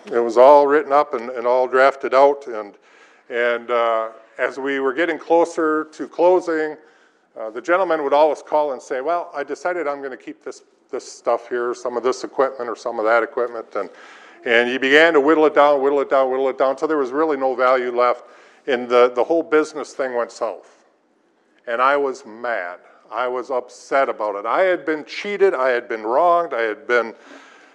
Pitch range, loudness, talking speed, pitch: 125-160 Hz, -19 LUFS, 210 wpm, 140 Hz